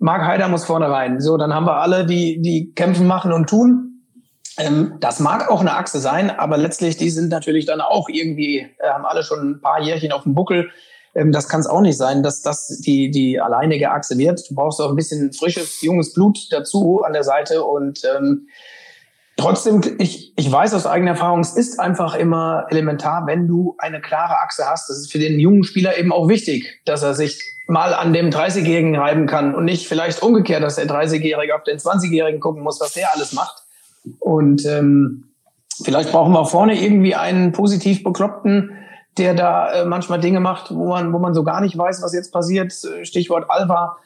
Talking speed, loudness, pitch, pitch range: 205 wpm, -17 LUFS, 170 Hz, 155-185 Hz